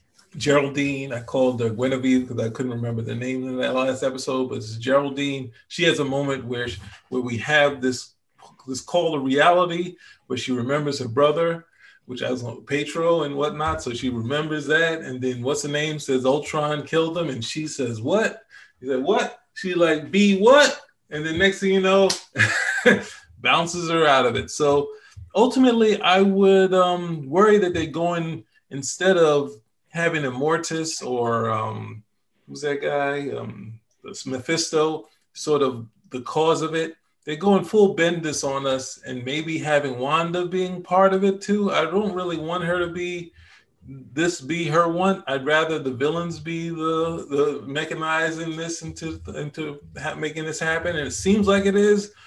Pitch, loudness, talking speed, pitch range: 155 Hz, -22 LUFS, 175 wpm, 130-170 Hz